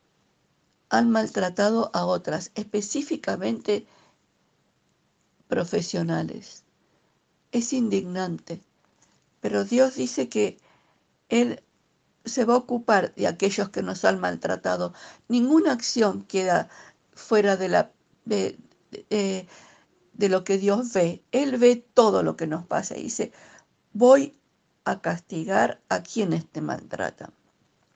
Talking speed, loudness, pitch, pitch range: 115 wpm, -25 LUFS, 200 Hz, 175-235 Hz